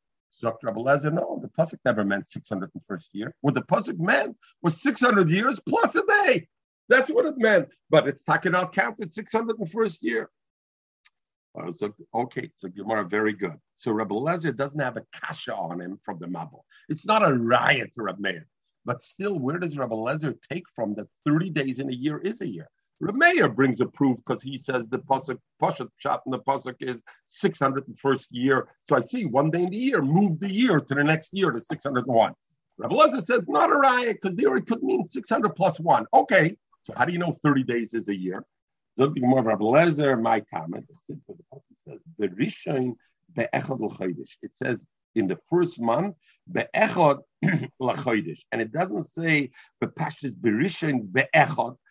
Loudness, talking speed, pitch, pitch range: -25 LUFS, 185 wpm, 145 Hz, 125-190 Hz